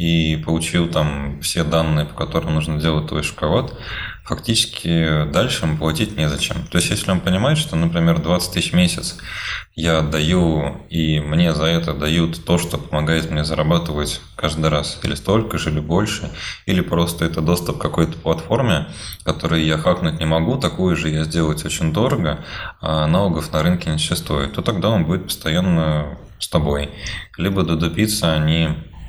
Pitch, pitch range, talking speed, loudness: 80 Hz, 80-85 Hz, 165 wpm, -19 LUFS